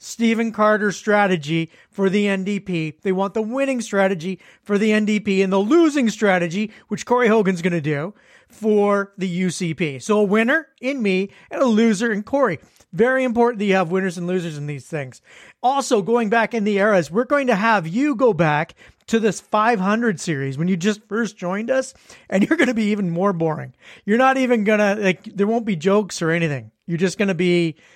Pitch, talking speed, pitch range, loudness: 205 Hz, 200 wpm, 185-230 Hz, -20 LUFS